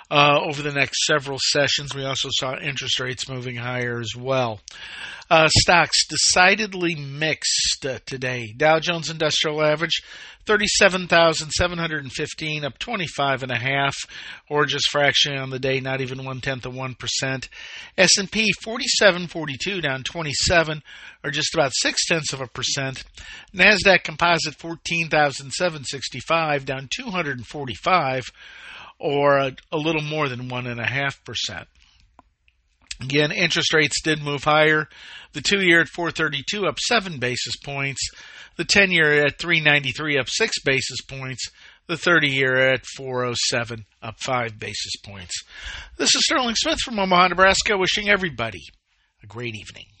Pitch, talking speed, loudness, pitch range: 145 Hz, 135 wpm, -20 LUFS, 130-170 Hz